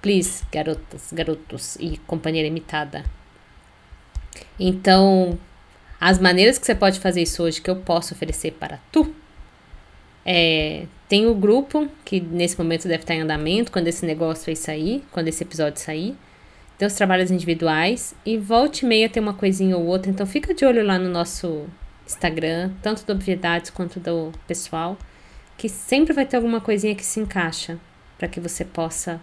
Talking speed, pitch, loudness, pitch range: 170 wpm, 180 Hz, -21 LUFS, 165-210 Hz